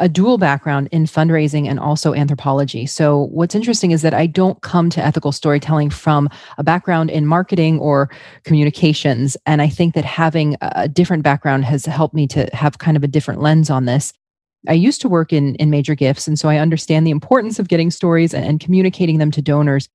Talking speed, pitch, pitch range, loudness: 210 wpm, 155 Hz, 145-165 Hz, -15 LUFS